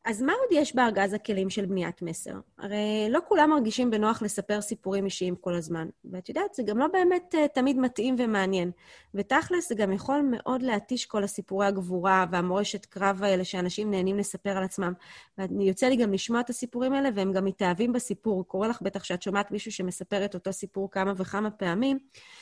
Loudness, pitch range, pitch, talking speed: -28 LUFS, 190-245 Hz, 205 Hz, 185 wpm